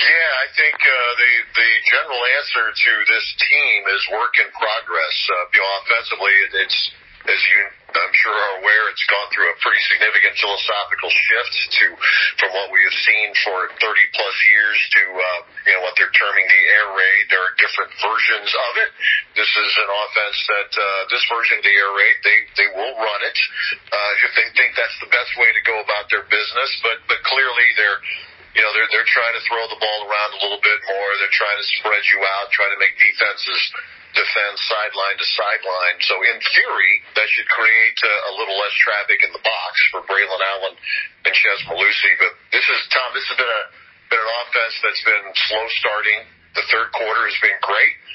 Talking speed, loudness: 200 wpm, -15 LUFS